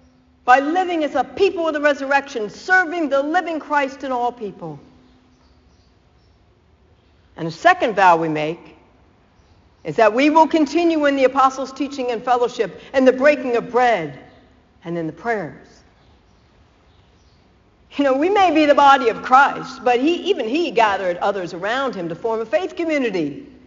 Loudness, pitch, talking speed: -18 LUFS, 245 Hz, 160 wpm